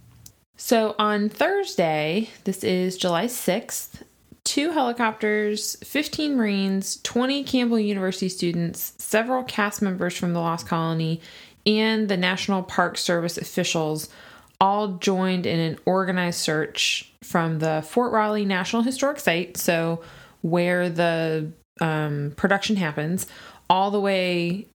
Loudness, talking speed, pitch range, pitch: -24 LUFS, 120 wpm, 170-215 Hz, 185 Hz